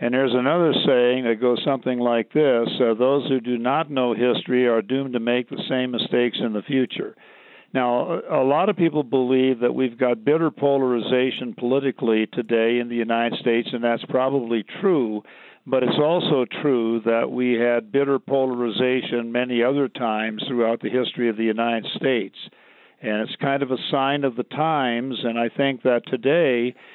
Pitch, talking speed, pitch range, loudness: 125 Hz, 180 wpm, 120-130 Hz, -22 LUFS